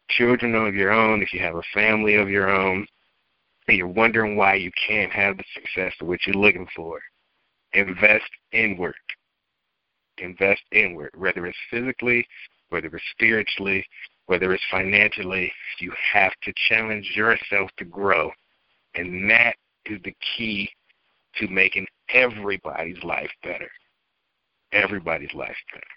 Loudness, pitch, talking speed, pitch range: -21 LUFS, 100 Hz, 135 wpm, 95-110 Hz